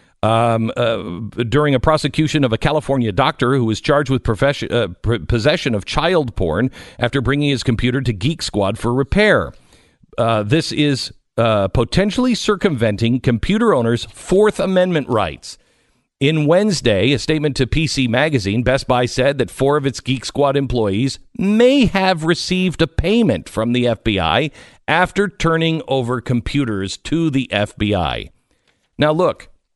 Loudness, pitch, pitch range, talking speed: -17 LUFS, 135 Hz, 115-155 Hz, 145 wpm